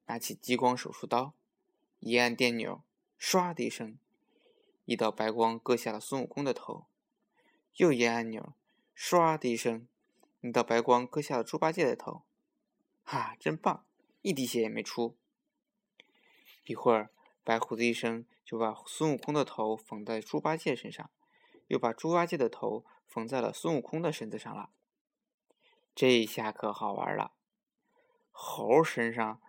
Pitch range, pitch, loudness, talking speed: 115-170 Hz, 125 Hz, -32 LUFS, 215 characters per minute